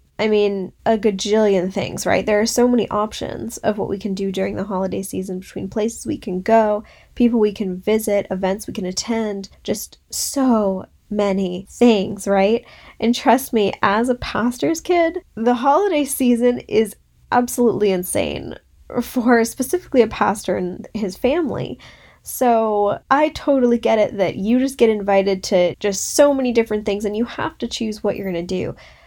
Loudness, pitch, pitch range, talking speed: -19 LUFS, 215 Hz, 195-240 Hz, 175 wpm